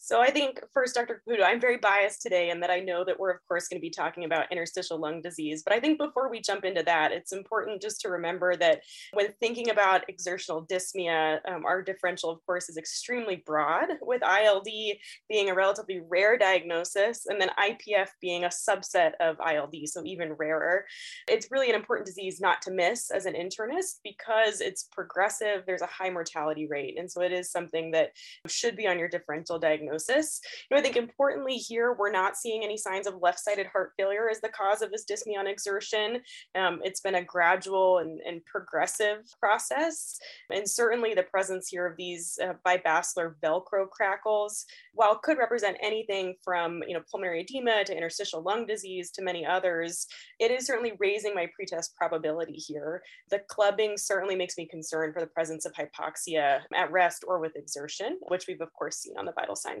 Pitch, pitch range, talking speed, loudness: 190 Hz, 175-215 Hz, 195 wpm, -29 LUFS